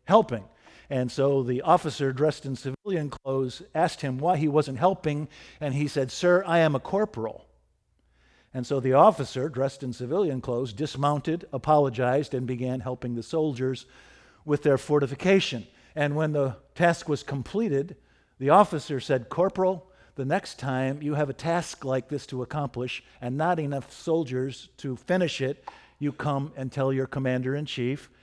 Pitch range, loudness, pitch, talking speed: 130-155 Hz, -27 LUFS, 140 Hz, 165 wpm